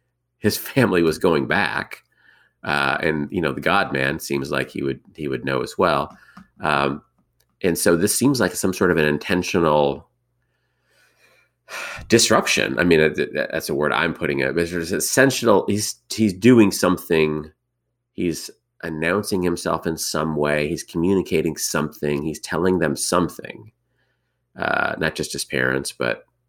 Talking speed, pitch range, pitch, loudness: 150 wpm, 75-110 Hz, 85 Hz, -20 LUFS